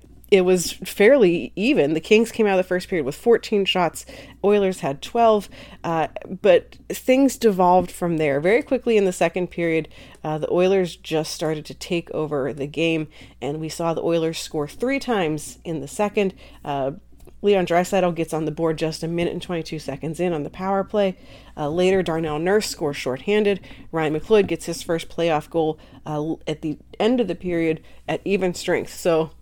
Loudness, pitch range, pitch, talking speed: -22 LUFS, 155-195 Hz, 170 Hz, 190 wpm